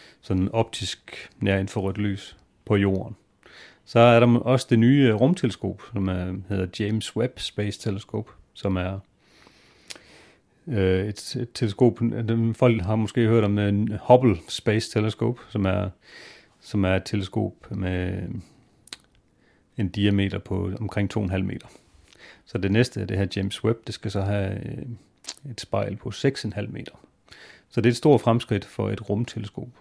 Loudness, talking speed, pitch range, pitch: -24 LUFS, 145 wpm, 100-115 Hz, 105 Hz